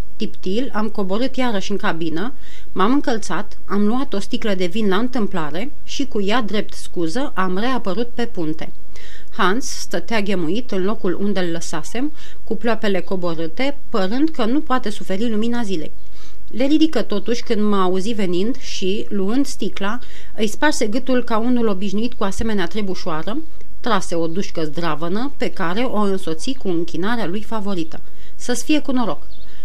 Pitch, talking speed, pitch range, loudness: 210 Hz, 160 wpm, 185-245 Hz, -22 LUFS